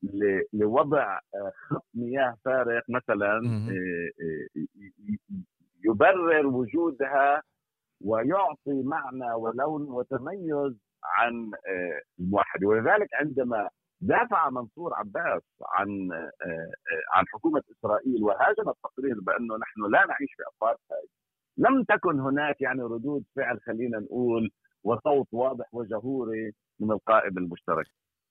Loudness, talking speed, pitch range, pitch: -27 LUFS, 95 wpm, 110-145 Hz, 125 Hz